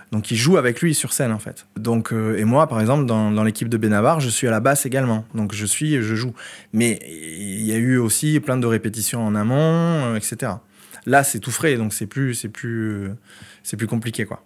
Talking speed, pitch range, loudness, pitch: 240 wpm, 110-130 Hz, -20 LUFS, 115 Hz